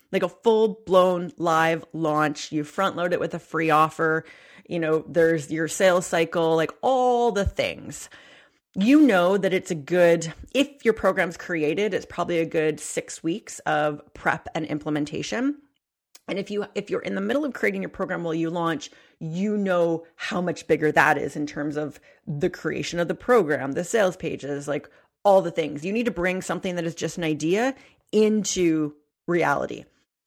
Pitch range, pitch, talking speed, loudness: 155-195 Hz, 170 Hz, 185 wpm, -24 LUFS